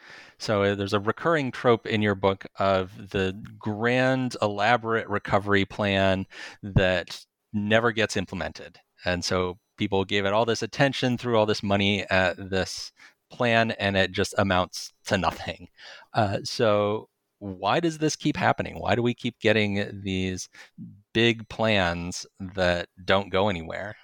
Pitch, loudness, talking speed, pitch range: 105 Hz, -25 LUFS, 145 wpm, 95-115 Hz